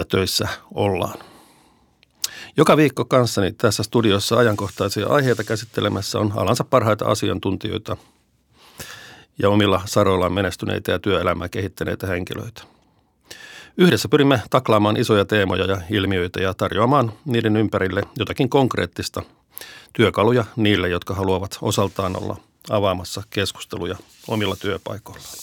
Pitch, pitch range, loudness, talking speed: 105 Hz, 95-115 Hz, -20 LUFS, 110 wpm